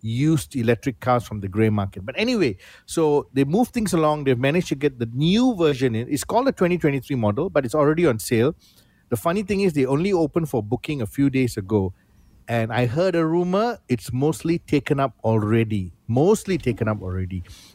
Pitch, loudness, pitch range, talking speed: 140 Hz, -22 LUFS, 115-165 Hz, 200 wpm